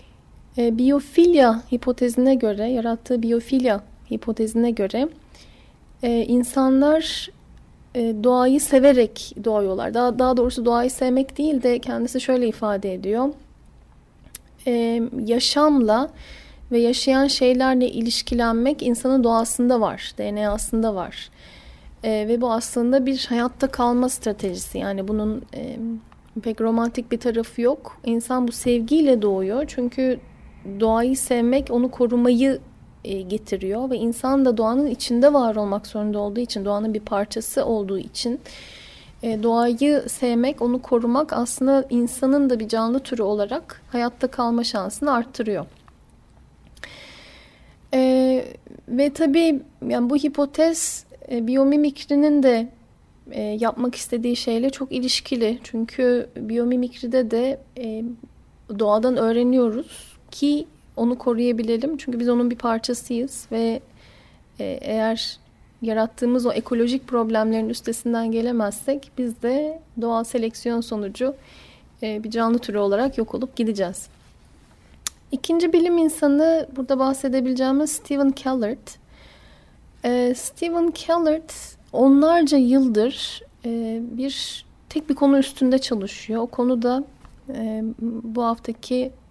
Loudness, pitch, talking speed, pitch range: -21 LUFS, 245 Hz, 110 wpm, 230-265 Hz